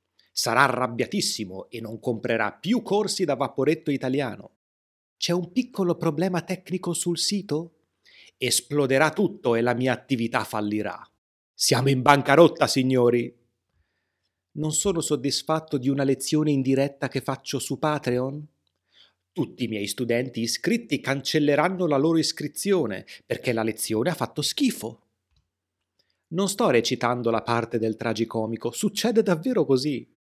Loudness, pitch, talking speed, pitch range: -24 LUFS, 135 Hz, 130 wpm, 115-155 Hz